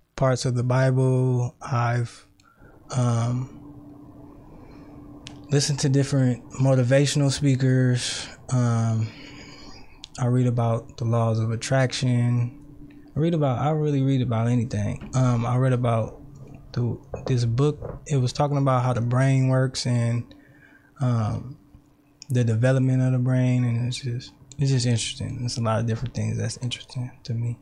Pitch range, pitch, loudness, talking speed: 120-140 Hz, 130 Hz, -24 LUFS, 140 wpm